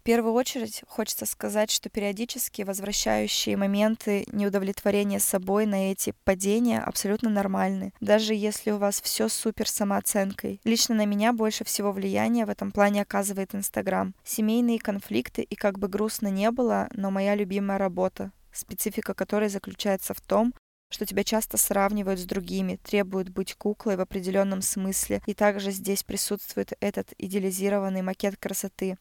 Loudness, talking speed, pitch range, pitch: -27 LUFS, 145 wpm, 195-215 Hz, 205 Hz